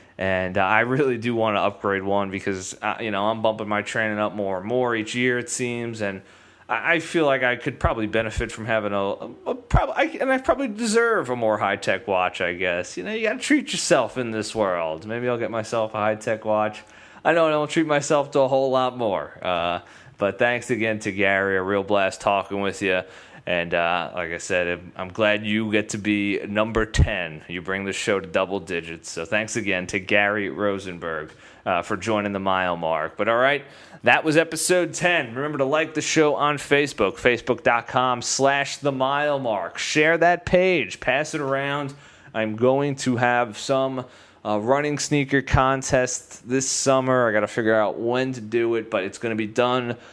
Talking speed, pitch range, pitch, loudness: 200 wpm, 100-135 Hz, 115 Hz, -23 LUFS